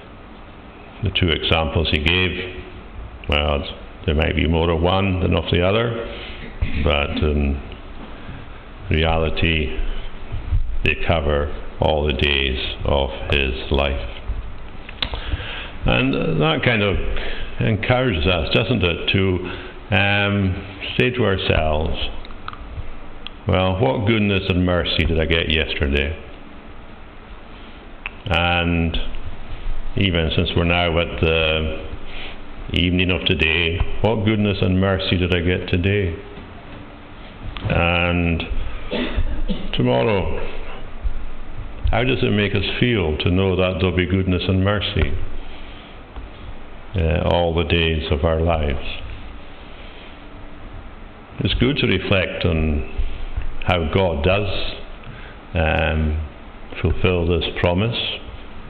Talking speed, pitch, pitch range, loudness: 105 wpm, 90 Hz, 80-100 Hz, -20 LUFS